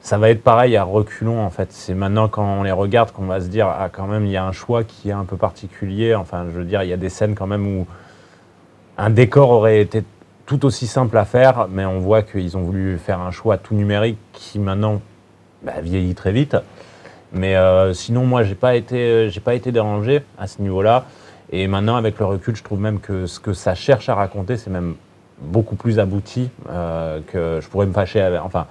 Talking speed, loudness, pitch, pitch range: 230 wpm, -18 LUFS, 100 Hz, 95-110 Hz